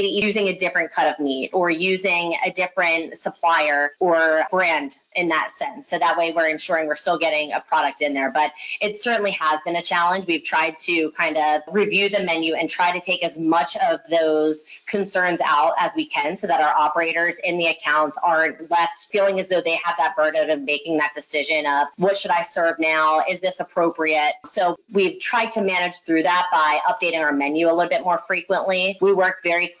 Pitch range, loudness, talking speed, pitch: 155-185 Hz, -20 LUFS, 210 wpm, 170 Hz